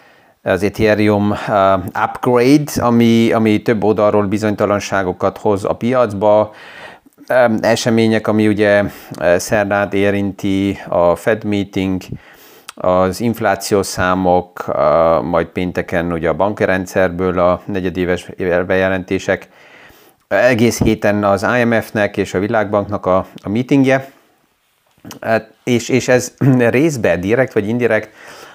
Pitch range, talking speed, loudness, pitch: 95-115 Hz, 100 wpm, -15 LUFS, 105 Hz